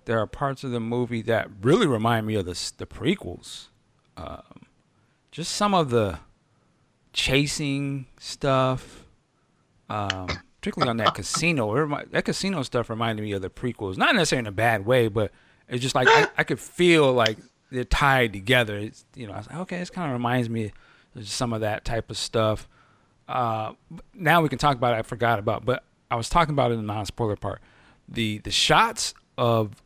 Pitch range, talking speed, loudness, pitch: 110-140 Hz, 195 wpm, -24 LUFS, 120 Hz